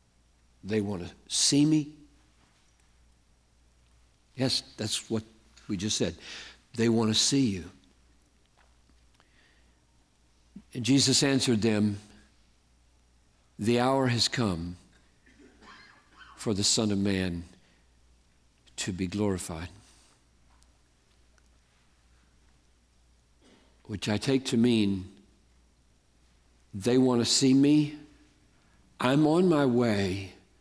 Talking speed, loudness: 90 wpm, -27 LUFS